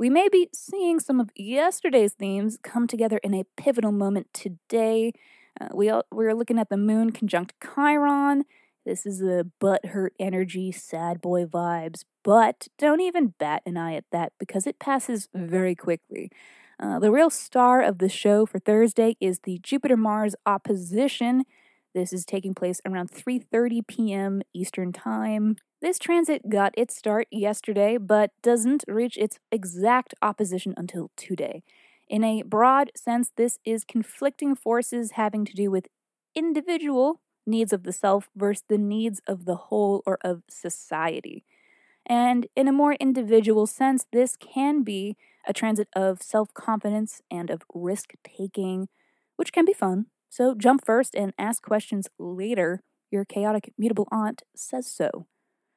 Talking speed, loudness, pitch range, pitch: 155 wpm, -25 LUFS, 195-250 Hz, 215 Hz